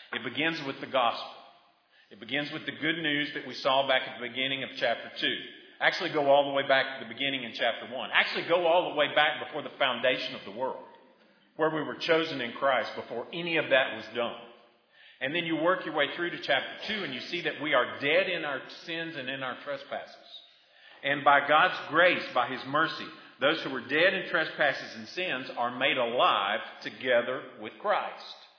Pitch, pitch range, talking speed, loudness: 145 Hz, 135-160 Hz, 215 wpm, -28 LUFS